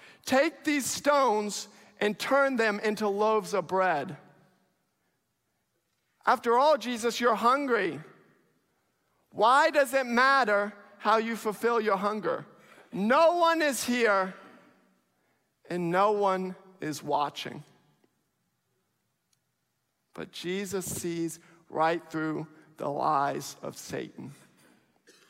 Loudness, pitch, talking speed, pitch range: -27 LUFS, 205 Hz, 100 wpm, 185-245 Hz